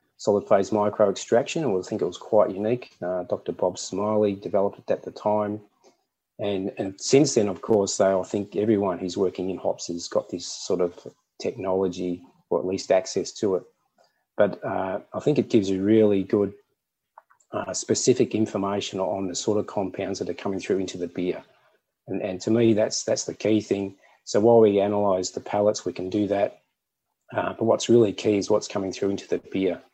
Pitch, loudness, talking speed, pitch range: 100 Hz, -24 LUFS, 200 wpm, 95-105 Hz